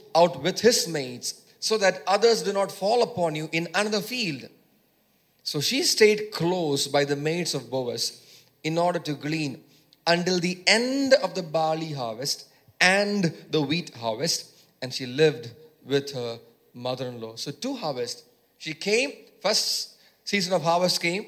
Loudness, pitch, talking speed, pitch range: -25 LUFS, 170 Hz, 155 wpm, 145-200 Hz